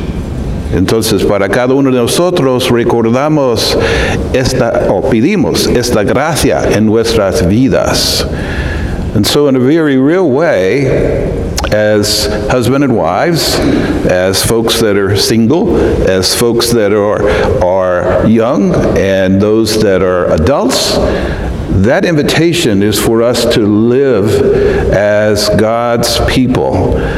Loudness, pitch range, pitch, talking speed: -10 LUFS, 95-120 Hz, 105 Hz, 115 wpm